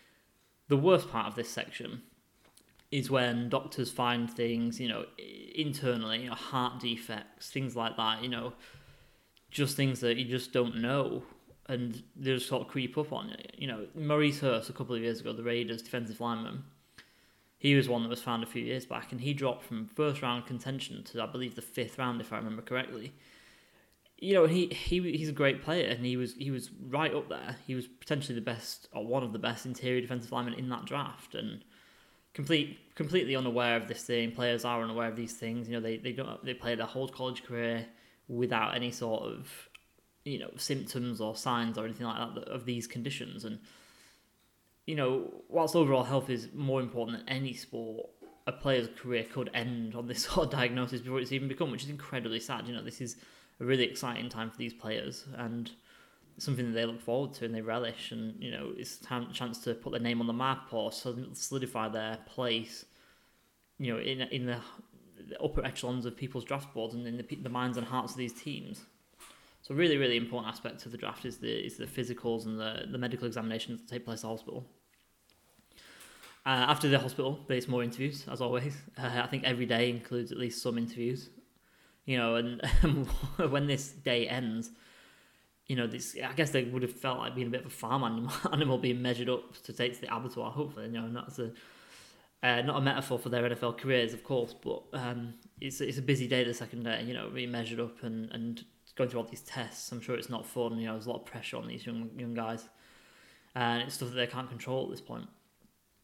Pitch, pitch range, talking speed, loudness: 125 Hz, 115-130 Hz, 215 wpm, -34 LUFS